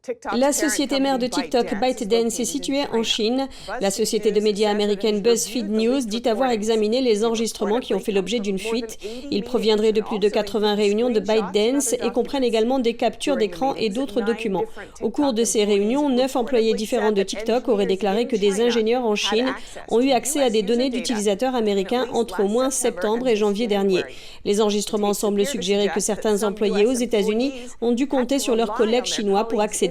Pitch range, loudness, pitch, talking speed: 215-250 Hz, -21 LUFS, 230 Hz, 195 wpm